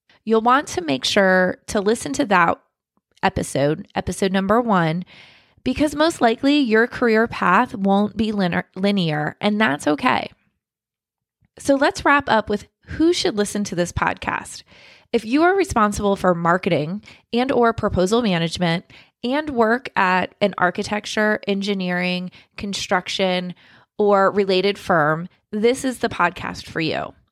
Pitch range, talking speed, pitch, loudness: 180-235 Hz, 140 wpm, 205 Hz, -20 LUFS